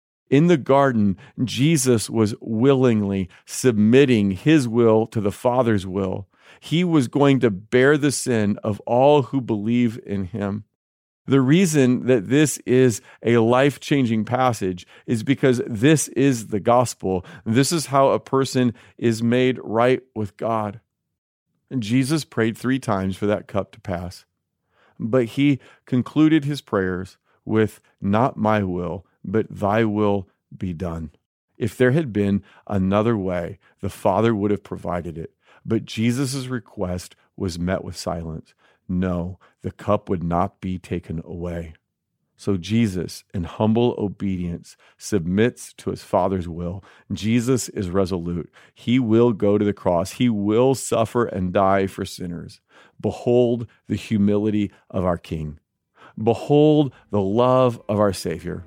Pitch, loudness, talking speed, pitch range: 110 Hz, -21 LUFS, 145 wpm, 95-125 Hz